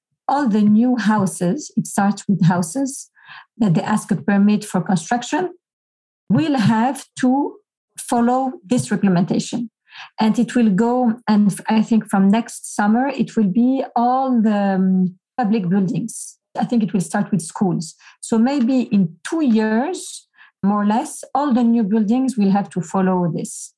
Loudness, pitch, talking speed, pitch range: -18 LUFS, 220 Hz, 160 wpm, 200-250 Hz